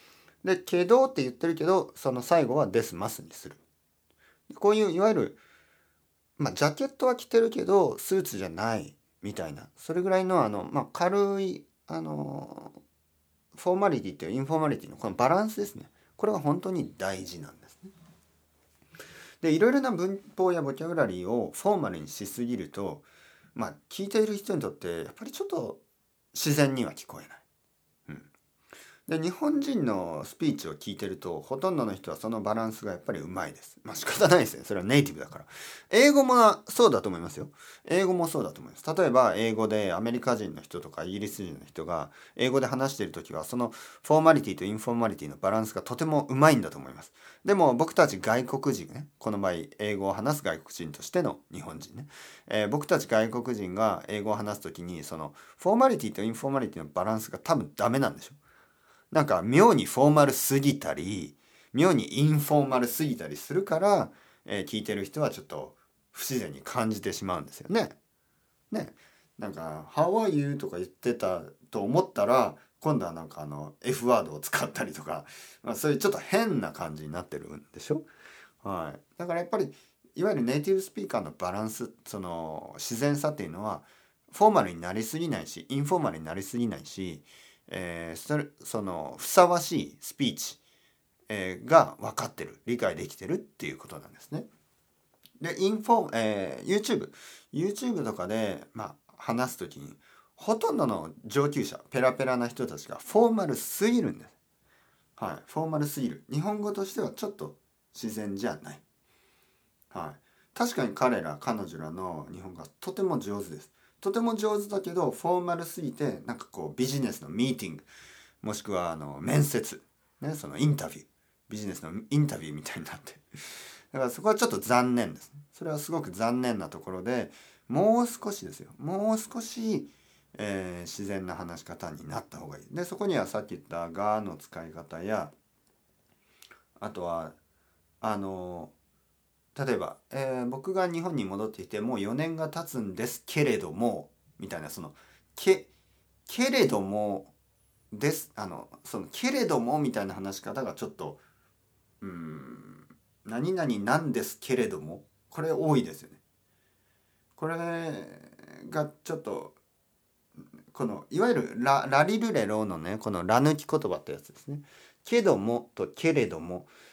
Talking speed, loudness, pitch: 360 characters per minute, -29 LUFS, 125 Hz